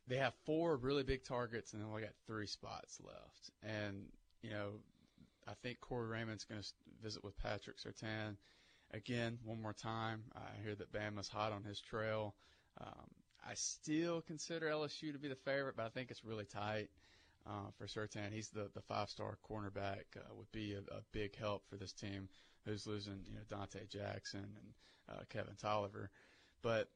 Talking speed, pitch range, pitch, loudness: 185 wpm, 100-115 Hz, 105 Hz, -46 LUFS